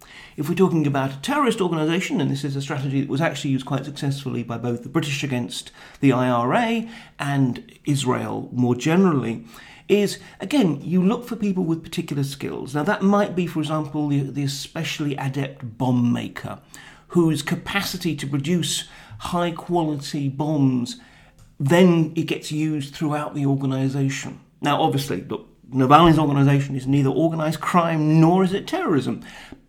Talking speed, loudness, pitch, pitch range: 155 wpm, -22 LUFS, 150 Hz, 135-170 Hz